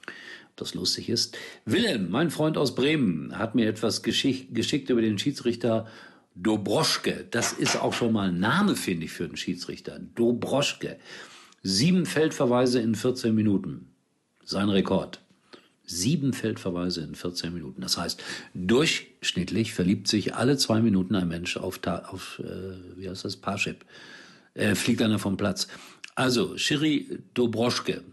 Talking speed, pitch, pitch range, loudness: 145 wpm, 115 Hz, 95-125 Hz, -26 LUFS